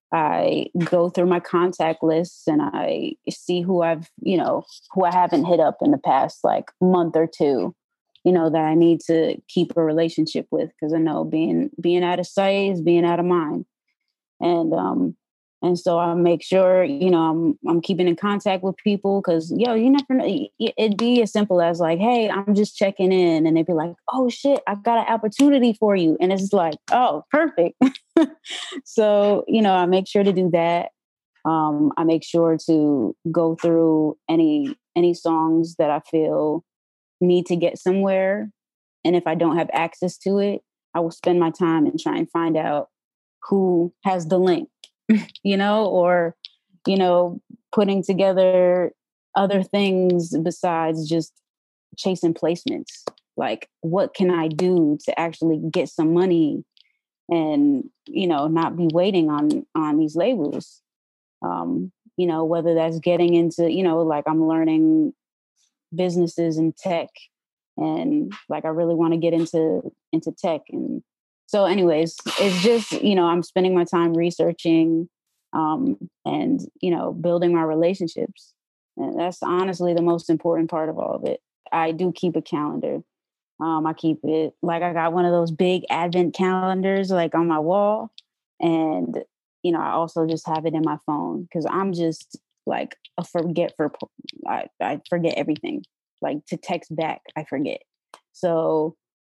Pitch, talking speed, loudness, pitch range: 175 Hz, 170 wpm, -21 LUFS, 165-200 Hz